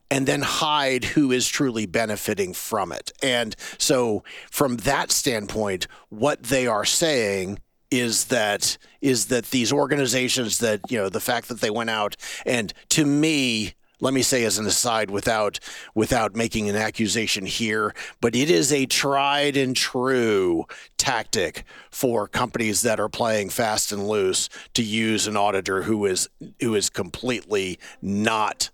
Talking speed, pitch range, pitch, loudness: 155 wpm, 105-135 Hz, 115 Hz, -22 LUFS